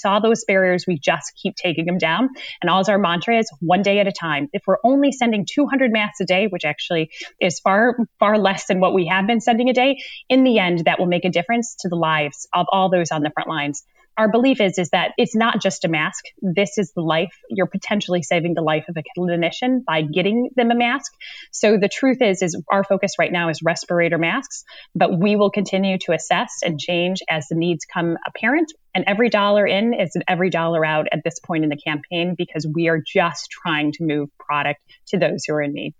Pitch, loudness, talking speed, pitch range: 185 Hz, -19 LUFS, 235 wpm, 165-210 Hz